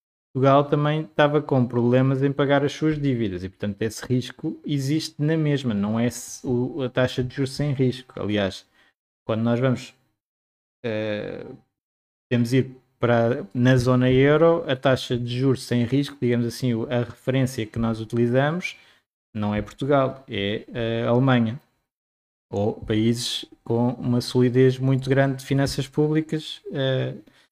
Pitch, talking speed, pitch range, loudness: 125 Hz, 145 wpm, 115-140 Hz, -23 LUFS